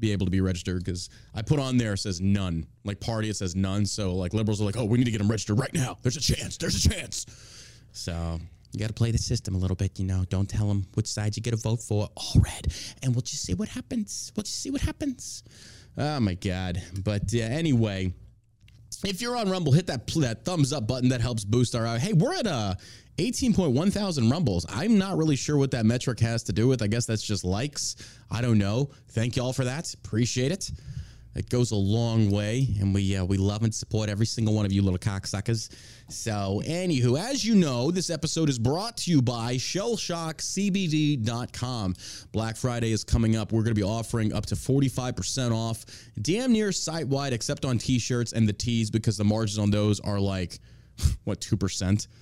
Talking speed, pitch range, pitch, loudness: 220 wpm, 105-130 Hz, 115 Hz, -27 LUFS